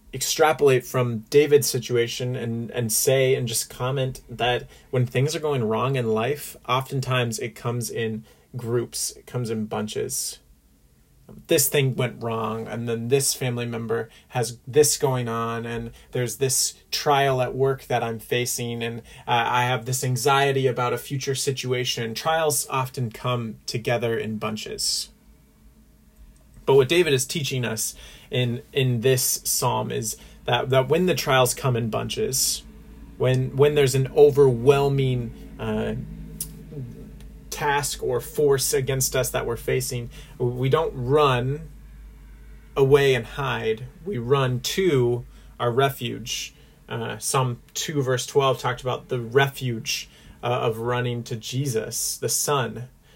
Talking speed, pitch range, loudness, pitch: 140 wpm, 115-135 Hz, -23 LUFS, 125 Hz